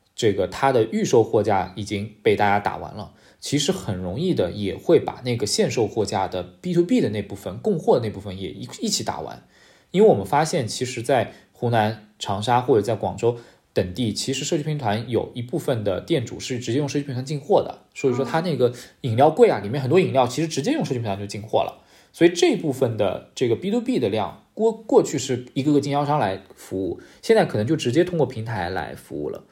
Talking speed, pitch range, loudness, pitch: 340 characters per minute, 105-150 Hz, -22 LUFS, 125 Hz